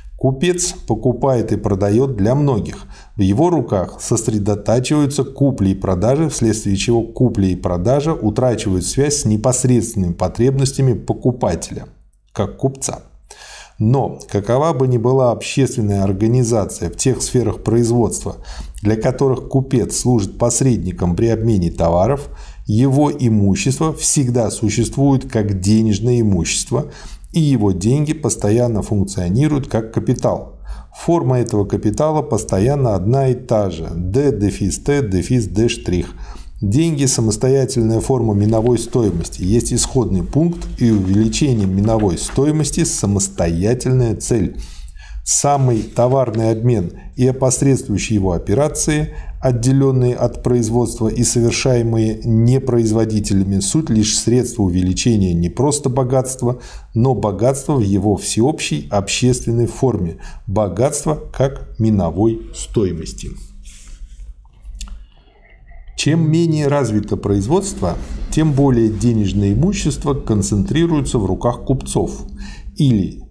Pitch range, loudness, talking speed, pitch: 105-135 Hz, -16 LUFS, 105 wpm, 115 Hz